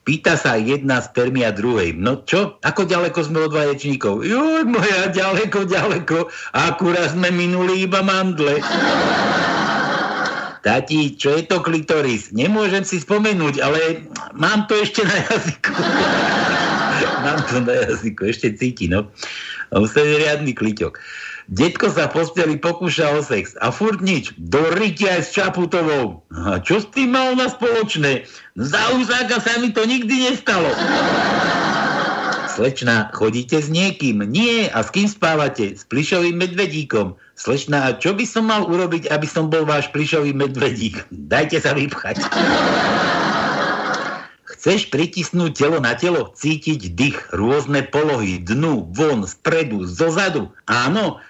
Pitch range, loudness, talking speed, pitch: 140-195 Hz, -18 LUFS, 135 wpm, 165 Hz